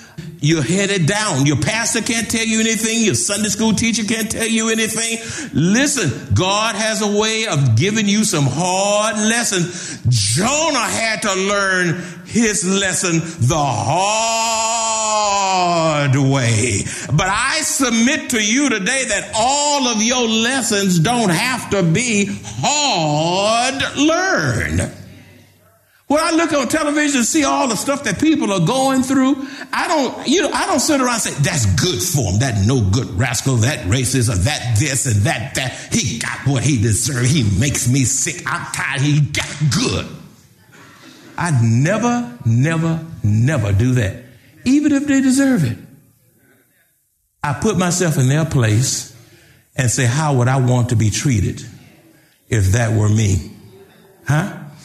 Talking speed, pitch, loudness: 155 wpm, 170 Hz, -16 LUFS